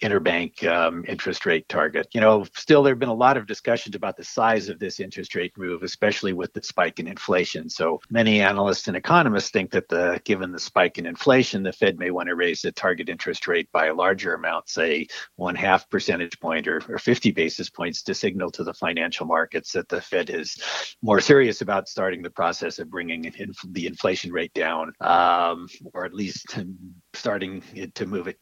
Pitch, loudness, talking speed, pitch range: 90 Hz, -23 LUFS, 205 wpm, 90-105 Hz